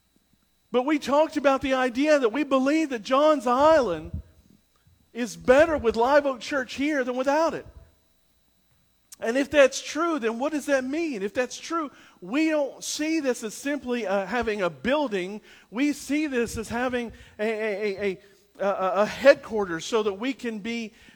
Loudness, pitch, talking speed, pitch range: -25 LUFS, 255 Hz, 170 wpm, 225-290 Hz